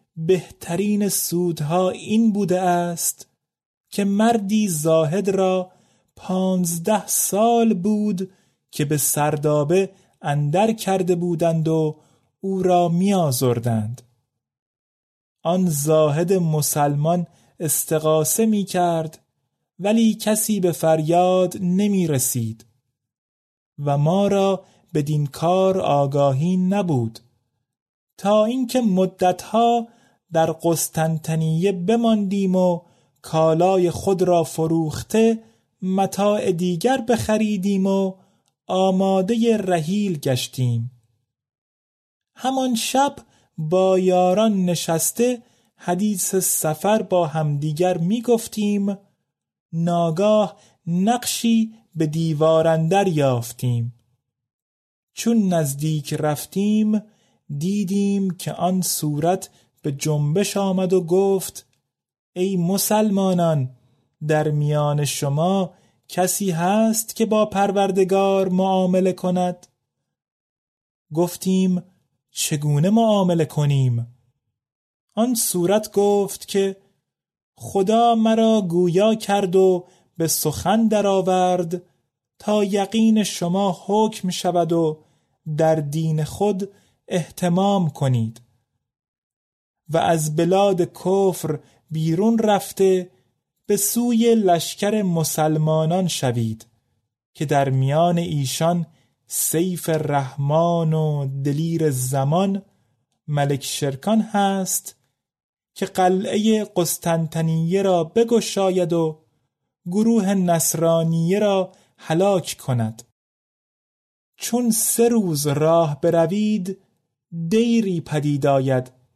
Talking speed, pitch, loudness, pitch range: 85 wpm, 180 Hz, -20 LUFS, 155-200 Hz